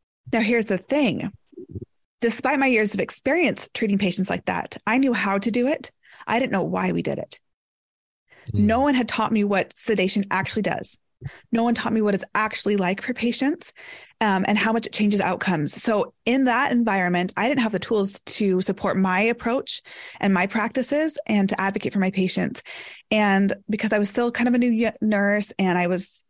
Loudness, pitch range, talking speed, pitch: -22 LUFS, 195-240 Hz, 200 wpm, 215 Hz